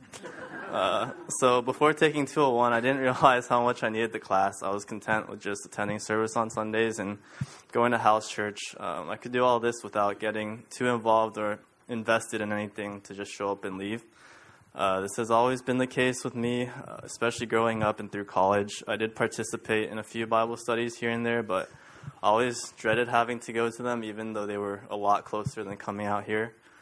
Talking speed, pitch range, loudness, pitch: 210 wpm, 105-120 Hz, -28 LUFS, 115 Hz